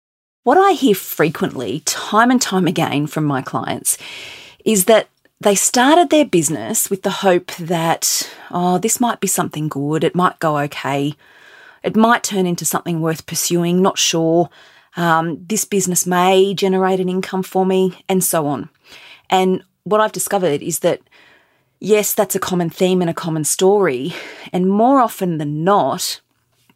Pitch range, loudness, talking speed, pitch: 165-205 Hz, -16 LUFS, 160 wpm, 185 Hz